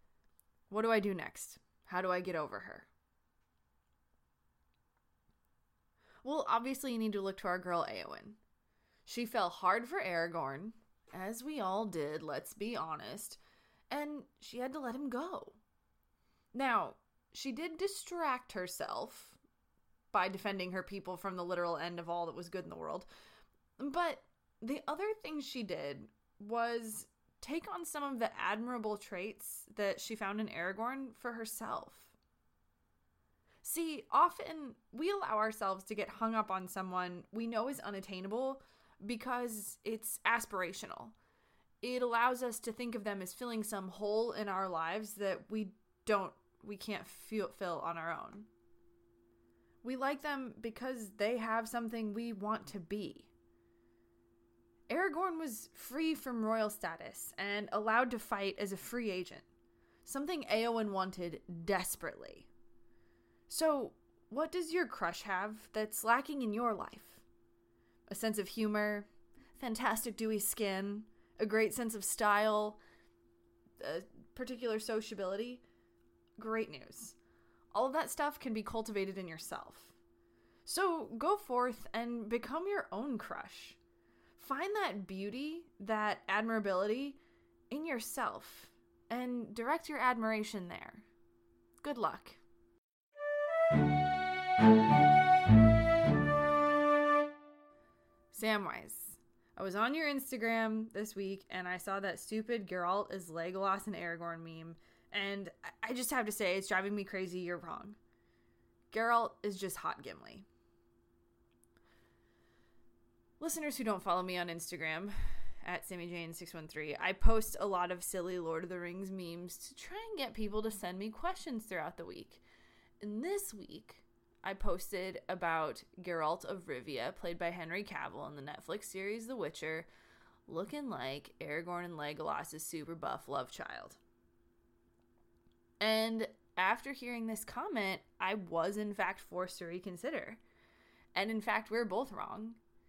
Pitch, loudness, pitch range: 205 Hz, -37 LUFS, 170-235 Hz